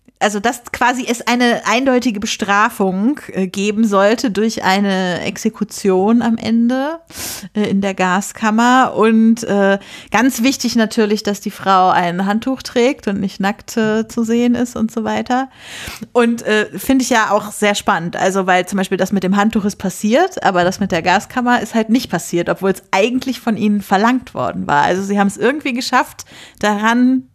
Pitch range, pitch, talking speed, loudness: 195-240 Hz, 215 Hz, 170 wpm, -16 LUFS